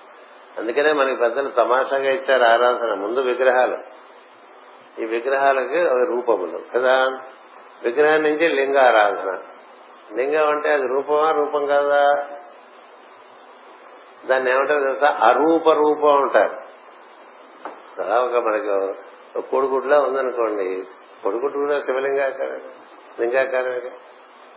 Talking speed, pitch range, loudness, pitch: 90 wpm, 125-145 Hz, -19 LUFS, 135 Hz